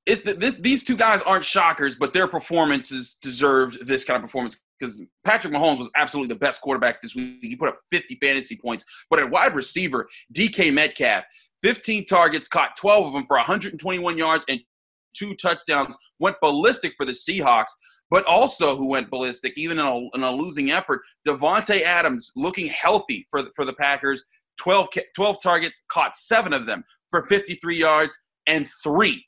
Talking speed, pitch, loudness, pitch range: 180 wpm, 170 Hz, -21 LUFS, 140-205 Hz